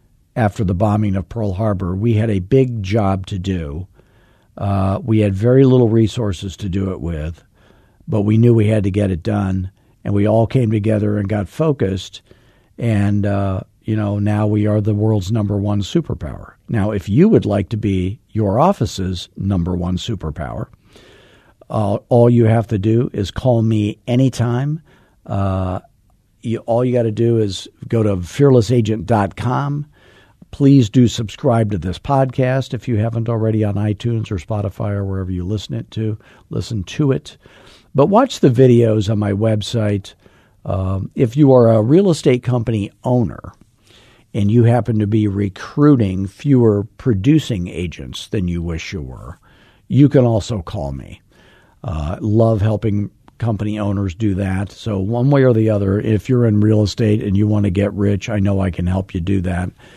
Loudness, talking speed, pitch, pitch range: -17 LUFS, 175 wpm, 105 Hz, 100-120 Hz